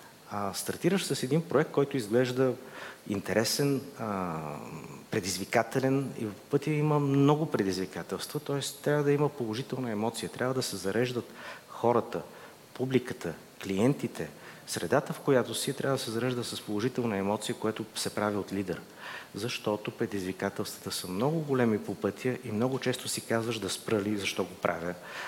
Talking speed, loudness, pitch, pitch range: 145 wpm, -31 LUFS, 115 Hz, 100-130 Hz